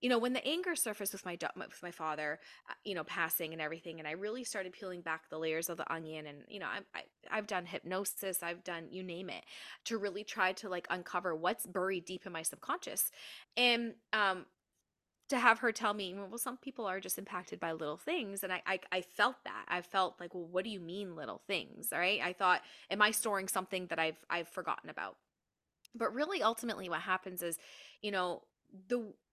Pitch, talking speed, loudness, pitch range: 185 Hz, 215 wpm, -37 LUFS, 170-210 Hz